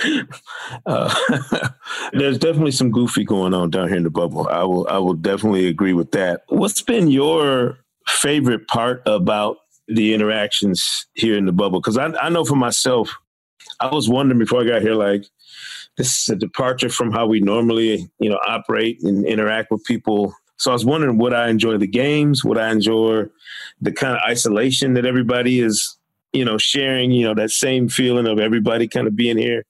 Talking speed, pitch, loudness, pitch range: 190 wpm, 115 Hz, -18 LUFS, 110-125 Hz